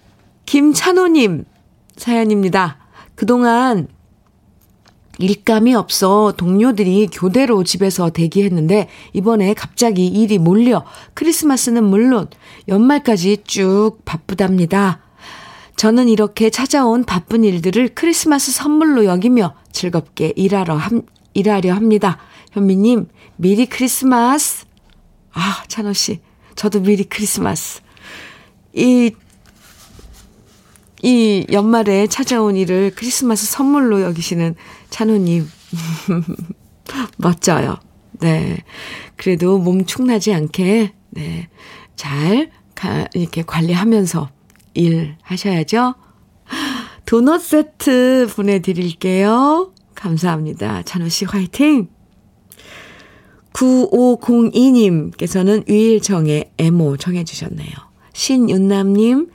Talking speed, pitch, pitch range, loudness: 215 characters per minute, 205 Hz, 180-235 Hz, -15 LUFS